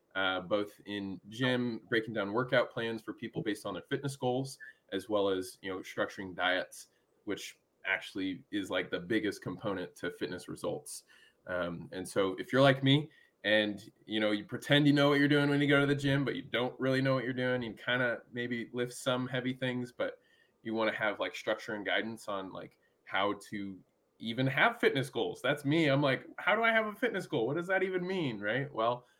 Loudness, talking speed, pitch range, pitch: -33 LUFS, 220 wpm, 110-145 Hz, 130 Hz